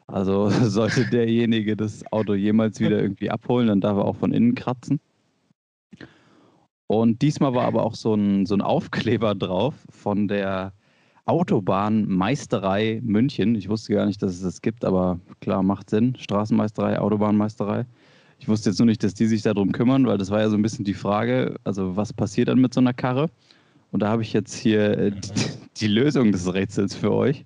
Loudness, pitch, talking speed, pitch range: -22 LUFS, 110 Hz, 185 wpm, 100-120 Hz